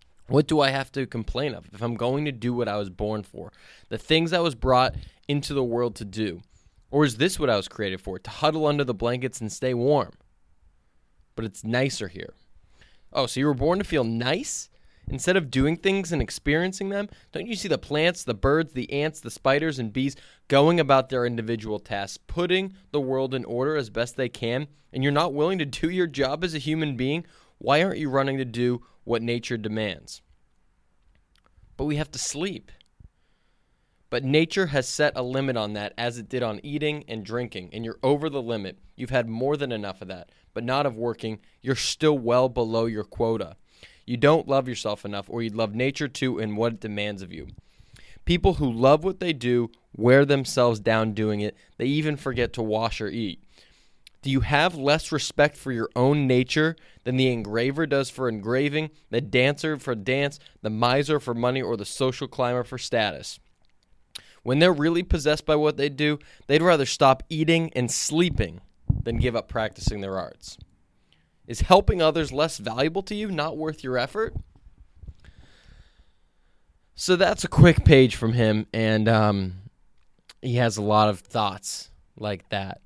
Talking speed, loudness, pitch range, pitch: 190 wpm, -24 LUFS, 110-150 Hz, 125 Hz